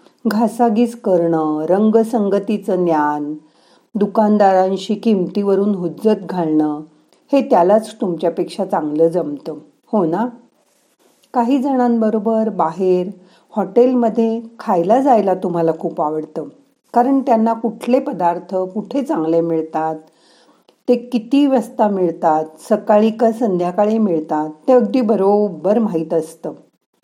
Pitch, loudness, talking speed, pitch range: 205 Hz, -17 LUFS, 100 wpm, 170-230 Hz